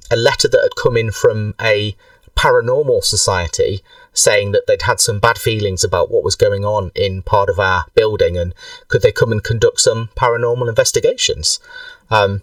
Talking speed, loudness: 180 wpm, -15 LUFS